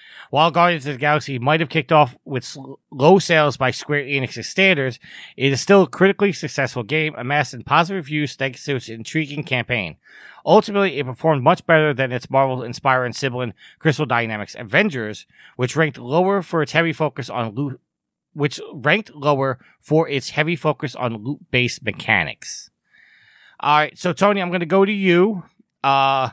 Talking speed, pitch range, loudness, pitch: 170 wpm, 130-165 Hz, -19 LUFS, 150 Hz